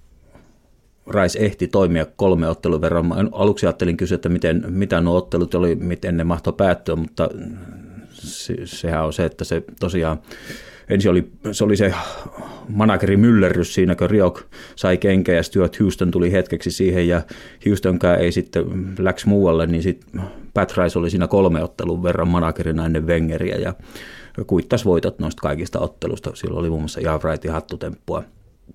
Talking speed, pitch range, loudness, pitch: 160 wpm, 85-95 Hz, -19 LUFS, 90 Hz